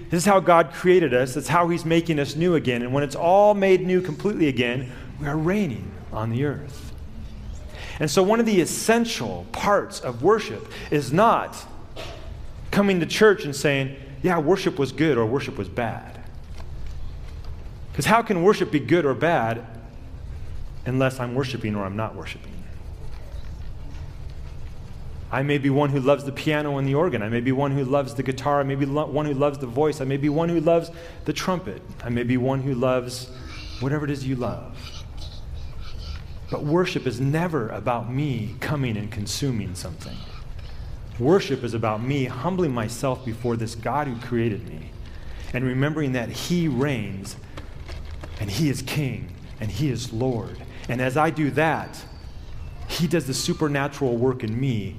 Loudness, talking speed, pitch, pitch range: -23 LUFS, 175 wpm, 130 Hz, 105-150 Hz